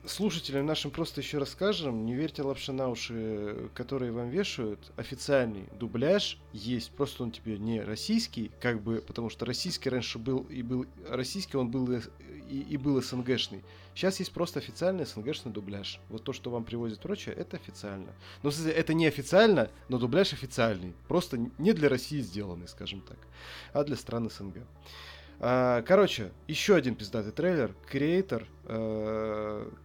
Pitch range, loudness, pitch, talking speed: 110-145 Hz, -31 LUFS, 125 Hz, 155 wpm